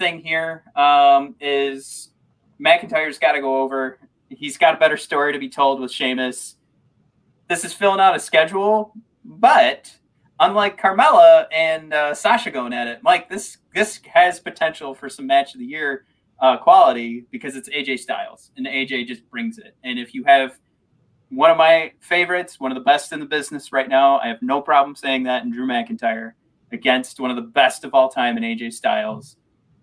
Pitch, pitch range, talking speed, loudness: 160 Hz, 135-225 Hz, 185 wpm, -18 LUFS